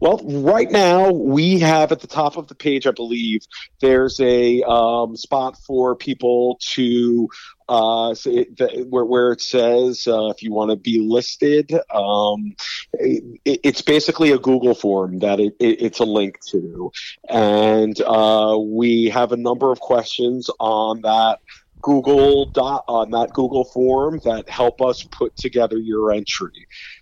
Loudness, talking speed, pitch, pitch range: -18 LUFS, 160 wpm, 120 Hz, 110-135 Hz